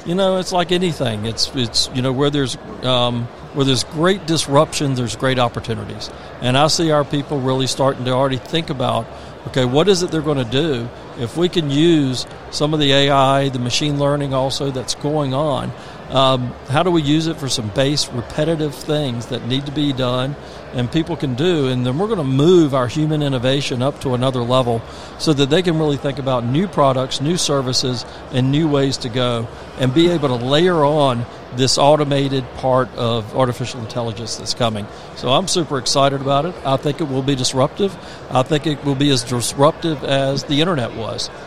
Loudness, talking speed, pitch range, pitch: -18 LUFS, 200 wpm, 125-155 Hz, 140 Hz